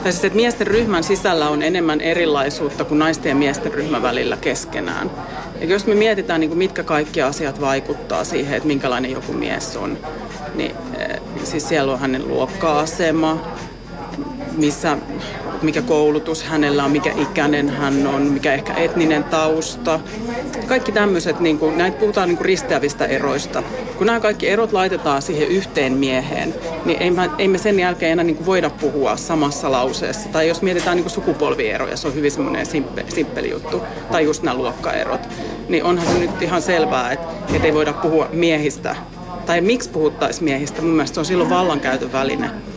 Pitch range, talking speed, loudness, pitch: 150-185 Hz, 165 wpm, -19 LUFS, 160 Hz